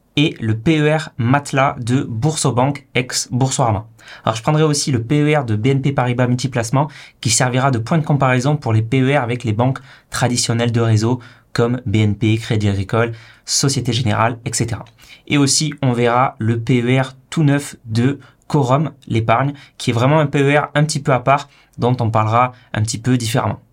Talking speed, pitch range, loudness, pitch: 170 wpm, 115-140 Hz, -17 LUFS, 125 Hz